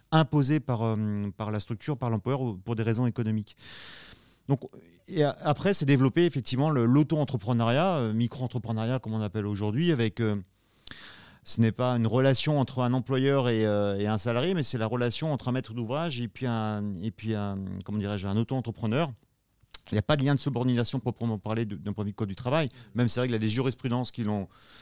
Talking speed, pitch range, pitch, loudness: 215 wpm, 110-135 Hz, 120 Hz, -28 LUFS